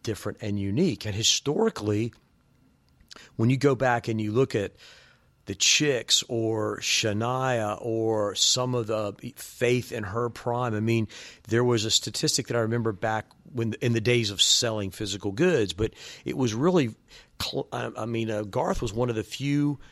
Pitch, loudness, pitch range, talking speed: 115 Hz, -26 LUFS, 110-125 Hz, 165 wpm